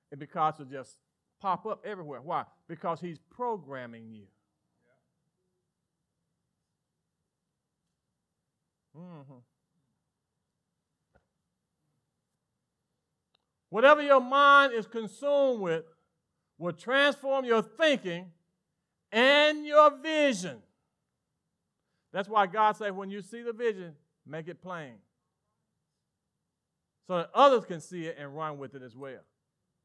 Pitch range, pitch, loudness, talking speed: 155-235 Hz, 180 Hz, -26 LUFS, 100 wpm